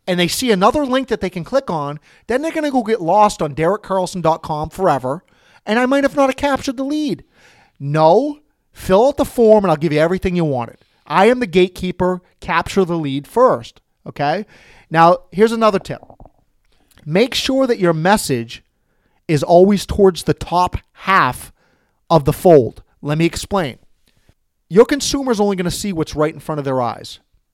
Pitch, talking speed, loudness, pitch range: 180 Hz, 180 wpm, -16 LUFS, 155-230 Hz